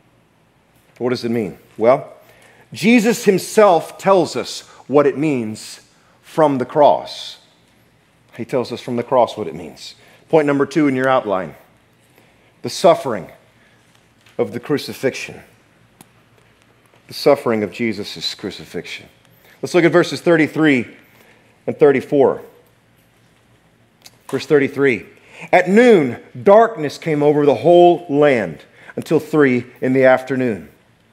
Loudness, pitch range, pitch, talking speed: -16 LUFS, 125-165 Hz, 145 Hz, 120 wpm